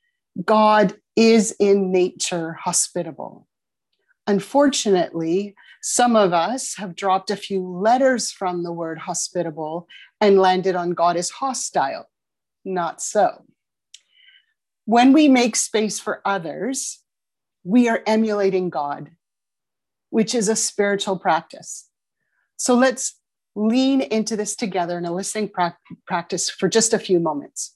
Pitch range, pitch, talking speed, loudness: 180-230 Hz, 200 Hz, 125 wpm, -20 LUFS